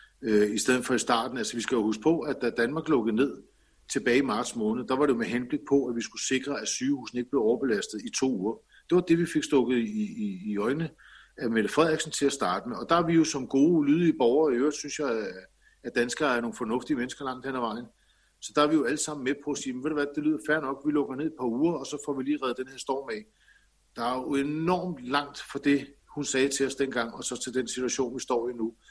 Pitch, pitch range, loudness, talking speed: 140 Hz, 125-155 Hz, -28 LUFS, 280 wpm